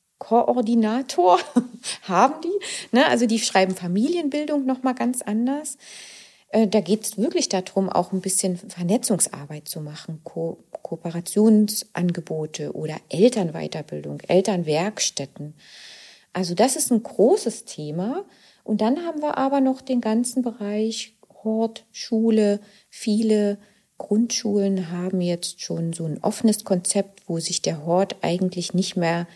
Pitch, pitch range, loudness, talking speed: 205 Hz, 180-235 Hz, -23 LUFS, 120 wpm